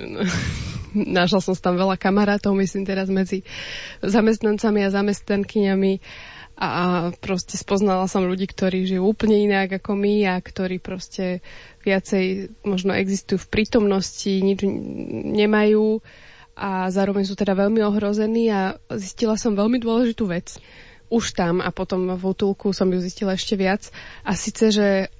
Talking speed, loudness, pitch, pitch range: 140 wpm, -21 LUFS, 195 Hz, 190-210 Hz